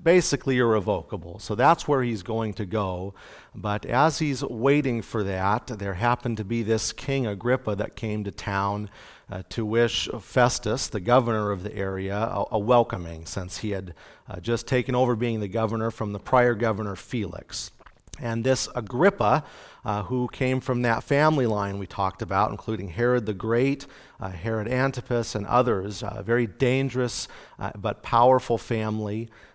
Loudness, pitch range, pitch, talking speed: -25 LUFS, 105-125 Hz, 115 Hz, 170 wpm